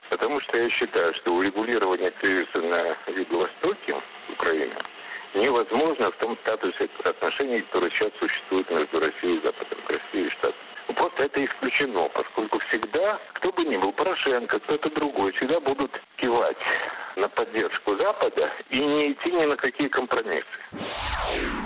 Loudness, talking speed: -25 LUFS, 140 wpm